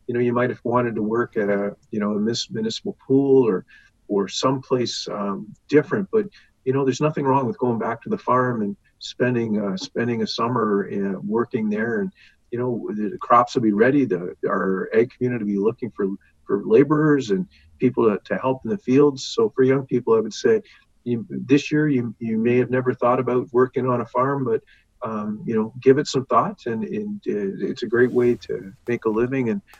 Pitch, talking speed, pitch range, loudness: 125 Hz, 215 wpm, 110-140 Hz, -22 LUFS